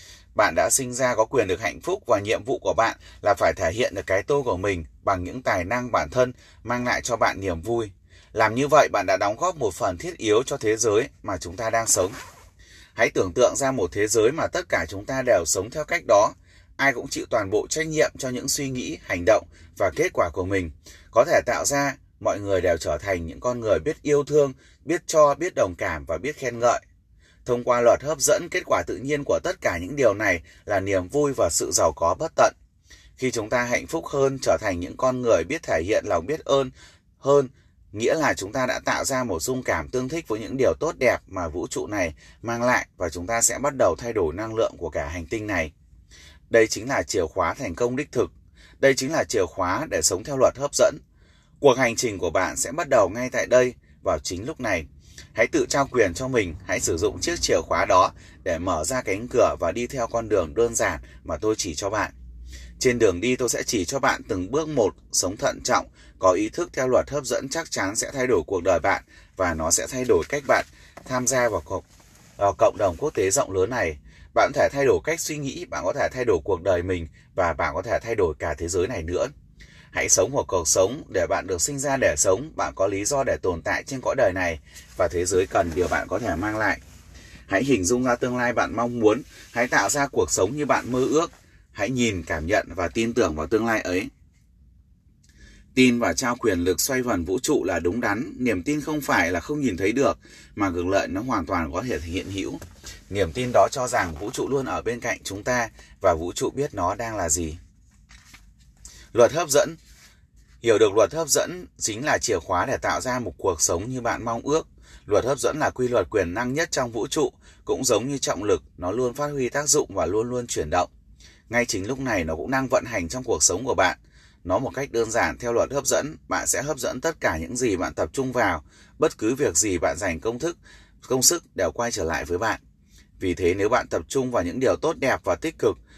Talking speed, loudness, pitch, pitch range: 245 wpm, -23 LUFS, 120 Hz, 90-135 Hz